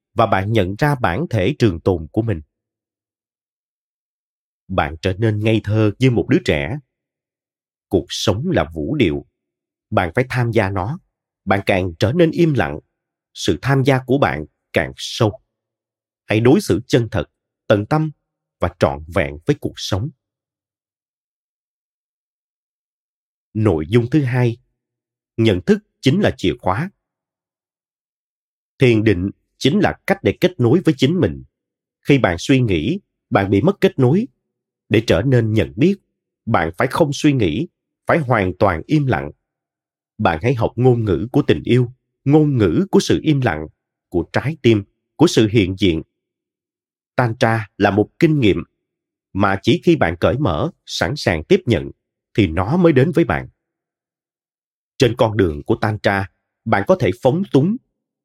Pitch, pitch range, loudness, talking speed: 115 Hz, 100-140 Hz, -18 LUFS, 160 wpm